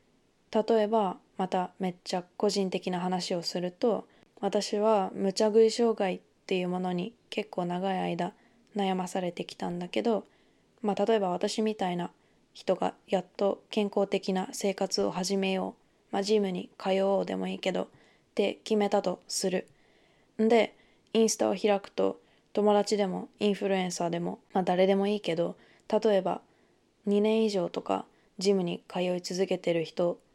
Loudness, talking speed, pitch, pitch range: -30 LUFS, 295 characters per minute, 195 Hz, 180-210 Hz